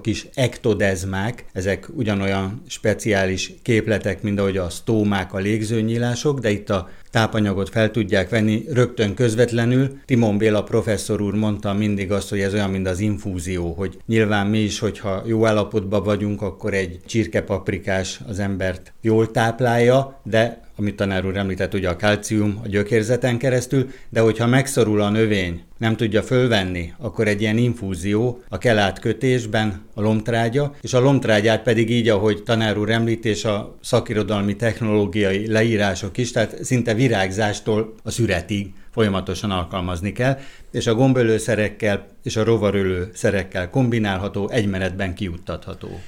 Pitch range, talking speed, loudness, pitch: 100-115 Hz, 140 wpm, -21 LUFS, 105 Hz